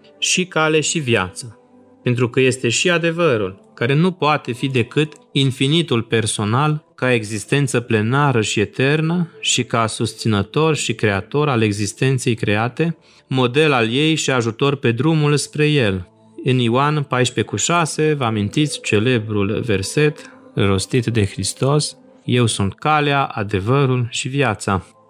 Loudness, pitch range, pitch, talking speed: -18 LUFS, 110-150 Hz, 130 Hz, 130 wpm